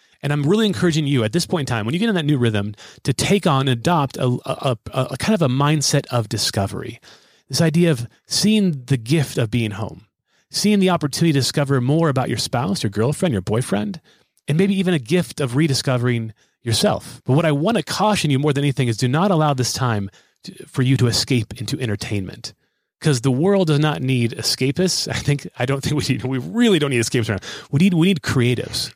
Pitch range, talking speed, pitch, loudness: 125-165 Hz, 230 wpm, 140 Hz, -19 LUFS